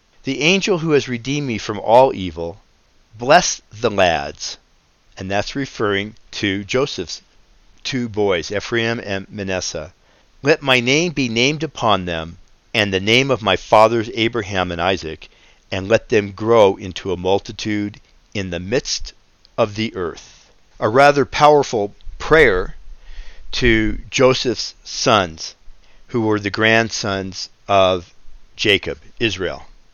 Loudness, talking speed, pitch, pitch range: -18 LUFS, 130 wpm, 110 Hz, 95-125 Hz